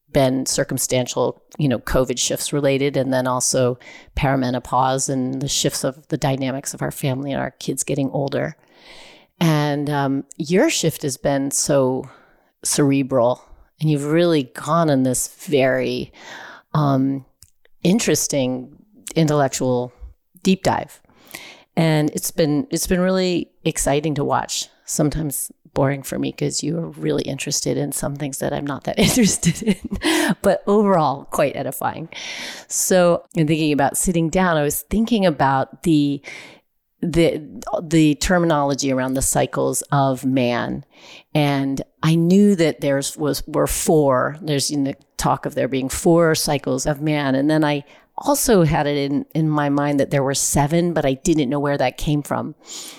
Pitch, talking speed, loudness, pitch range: 145 Hz, 155 wpm, -20 LUFS, 135-165 Hz